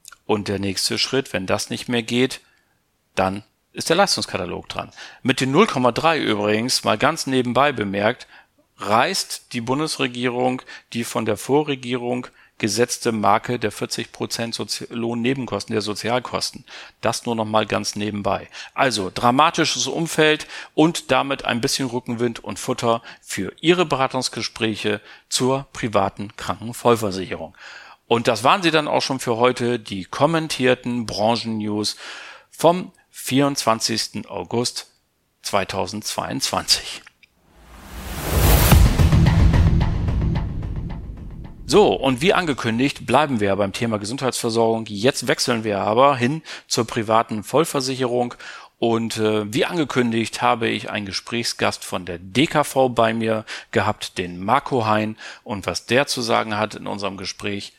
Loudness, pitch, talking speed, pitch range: -21 LUFS, 115 Hz, 125 wpm, 105-130 Hz